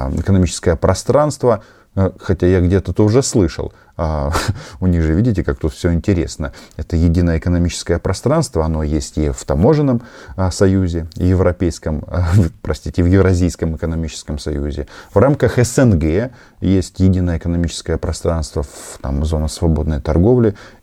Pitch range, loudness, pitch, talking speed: 80-100 Hz, -17 LUFS, 90 Hz, 125 wpm